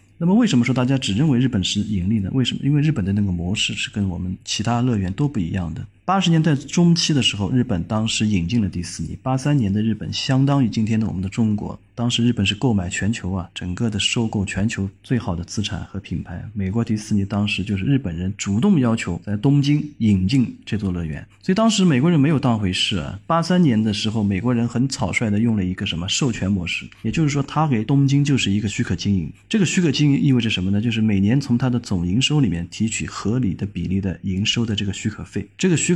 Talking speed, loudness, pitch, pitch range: 375 characters per minute, -20 LUFS, 110 Hz, 95-130 Hz